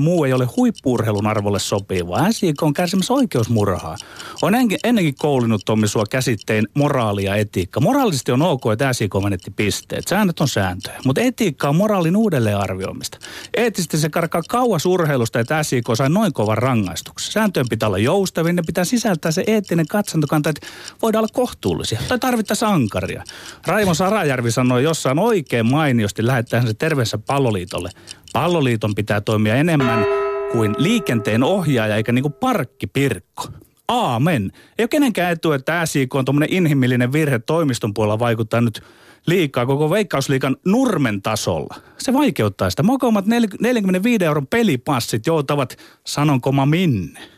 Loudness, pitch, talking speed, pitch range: -18 LUFS, 140 Hz, 145 wpm, 115-180 Hz